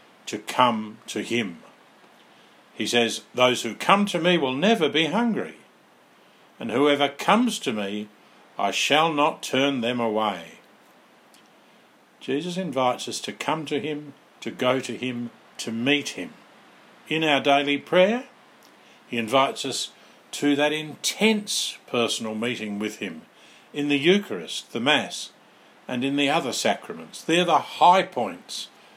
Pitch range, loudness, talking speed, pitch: 120-160 Hz, -24 LUFS, 140 wpm, 140 Hz